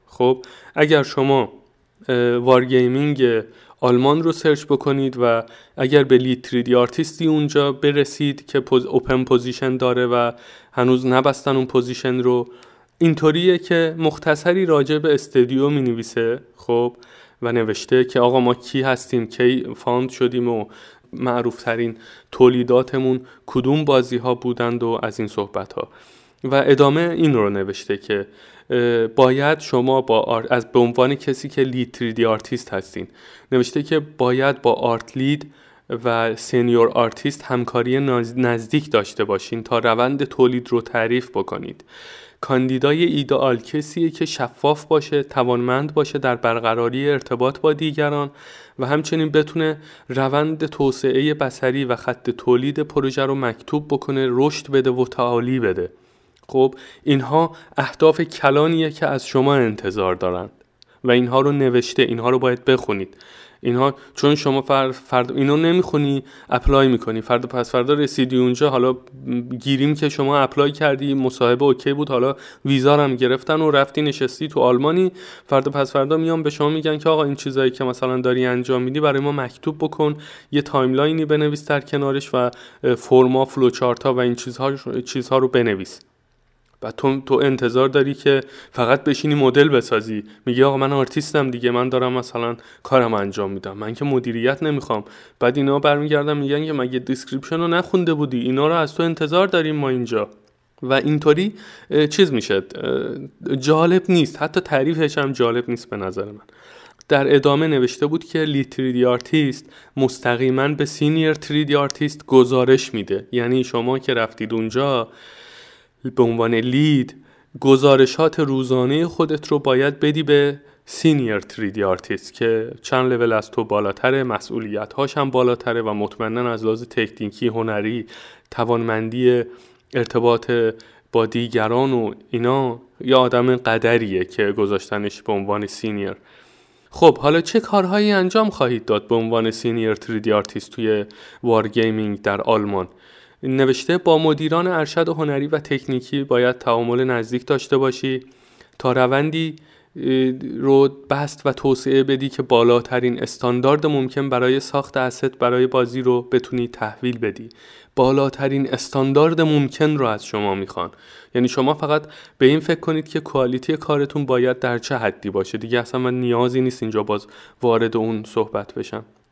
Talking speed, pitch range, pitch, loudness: 145 wpm, 120-145 Hz, 130 Hz, -19 LUFS